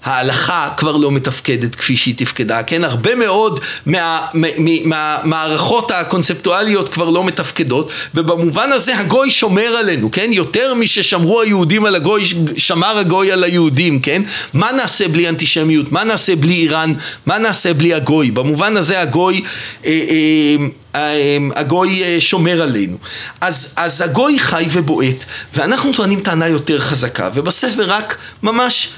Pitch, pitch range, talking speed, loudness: 170 Hz, 155-195 Hz, 150 wpm, -13 LUFS